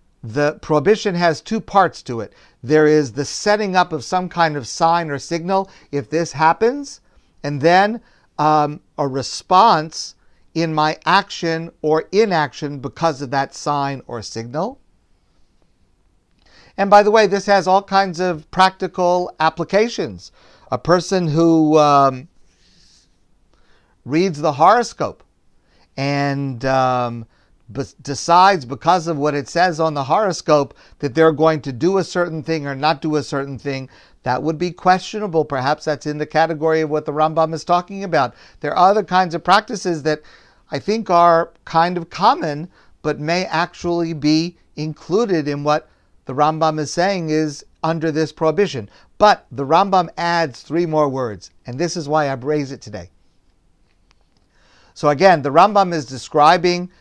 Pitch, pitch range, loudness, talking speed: 160 Hz, 140-180 Hz, -18 LUFS, 155 wpm